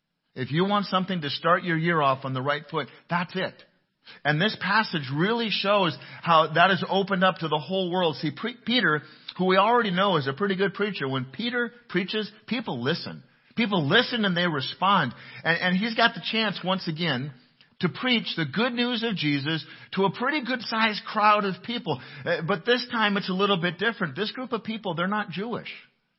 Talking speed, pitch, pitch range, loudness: 200 wpm, 190 Hz, 165-215 Hz, -25 LUFS